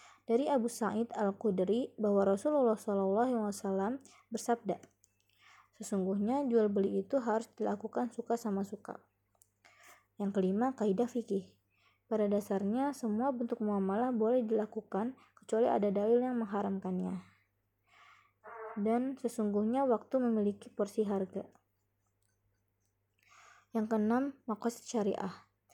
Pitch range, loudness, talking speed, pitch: 195-235 Hz, -34 LUFS, 105 wpm, 215 Hz